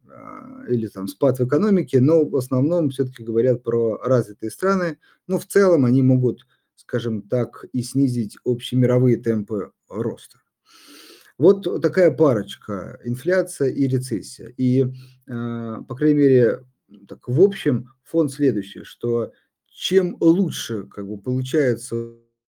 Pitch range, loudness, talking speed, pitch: 115-155 Hz, -21 LUFS, 125 wpm, 130 Hz